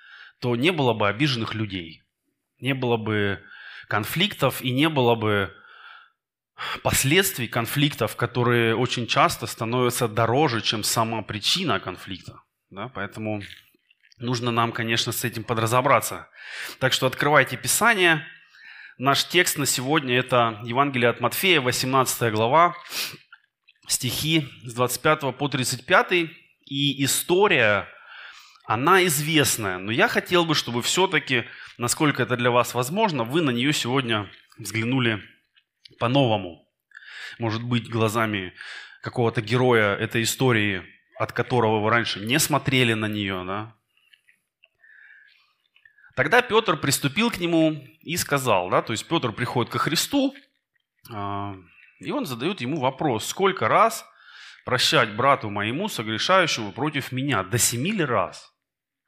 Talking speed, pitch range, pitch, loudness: 120 wpm, 115-145 Hz, 125 Hz, -22 LUFS